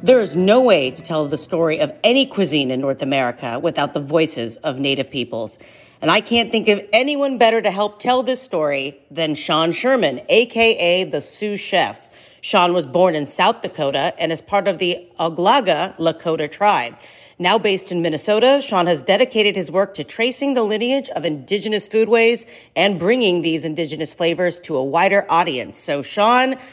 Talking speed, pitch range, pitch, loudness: 180 wpm, 155-220 Hz, 180 Hz, -18 LUFS